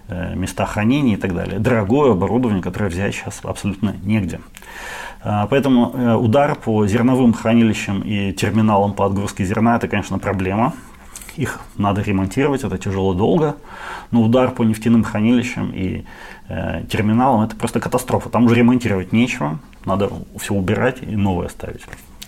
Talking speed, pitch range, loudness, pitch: 135 wpm, 95-120 Hz, -18 LUFS, 110 Hz